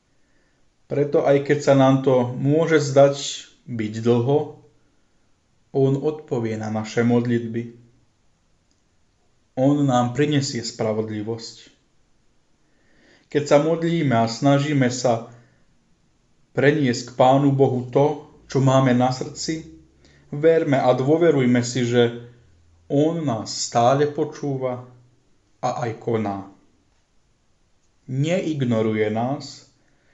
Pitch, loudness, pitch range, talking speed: 125 Hz, -21 LUFS, 115-145 Hz, 95 wpm